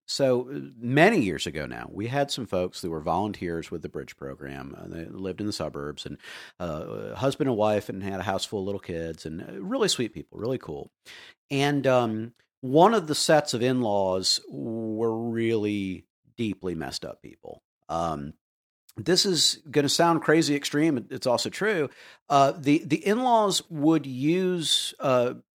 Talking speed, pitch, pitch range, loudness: 180 wpm, 115 Hz, 95-145 Hz, -26 LUFS